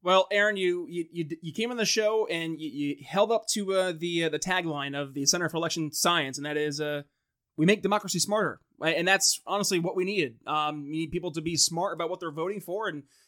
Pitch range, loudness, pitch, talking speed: 155-195 Hz, -27 LUFS, 170 Hz, 250 wpm